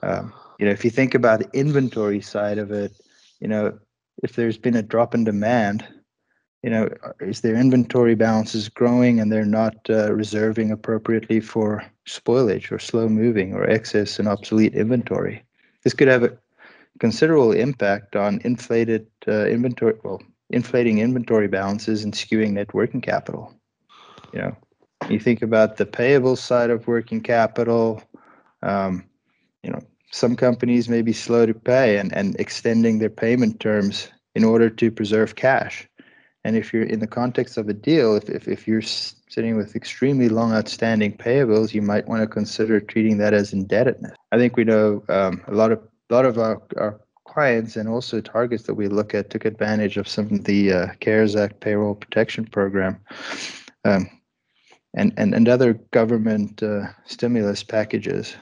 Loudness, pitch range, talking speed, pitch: -21 LUFS, 105-120 Hz, 170 wpm, 110 Hz